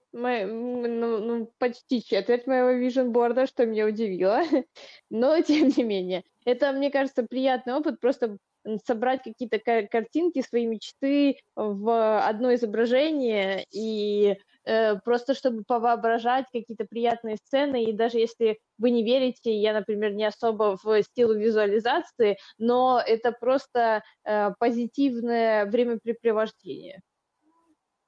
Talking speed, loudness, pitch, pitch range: 120 wpm, -25 LUFS, 235 Hz, 220-255 Hz